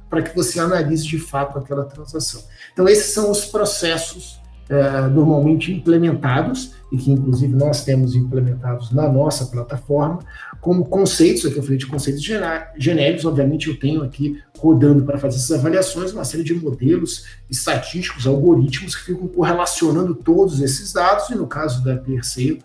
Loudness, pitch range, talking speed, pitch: -18 LUFS, 135-165 Hz, 155 wpm, 145 Hz